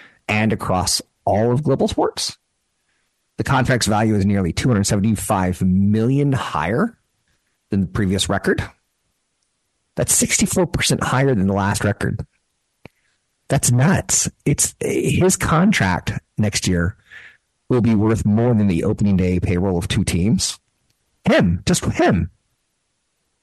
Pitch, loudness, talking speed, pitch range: 110 Hz, -18 LUFS, 120 wpm, 100-130 Hz